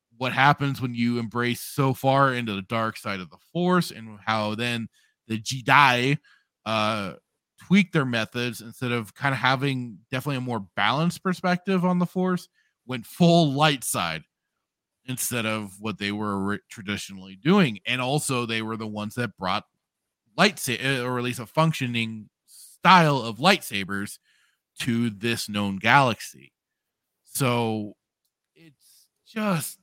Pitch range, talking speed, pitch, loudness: 110-145 Hz, 145 wpm, 120 Hz, -24 LUFS